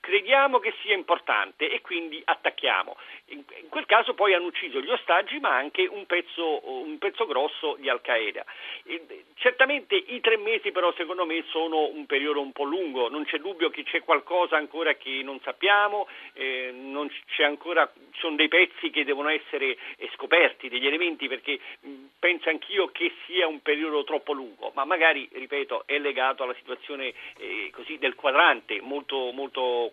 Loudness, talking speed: -25 LUFS, 165 wpm